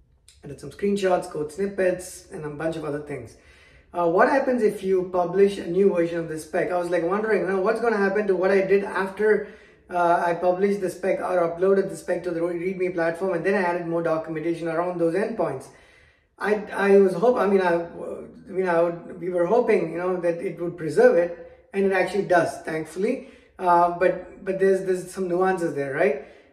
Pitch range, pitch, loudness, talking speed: 170-195 Hz, 180 Hz, -23 LUFS, 215 wpm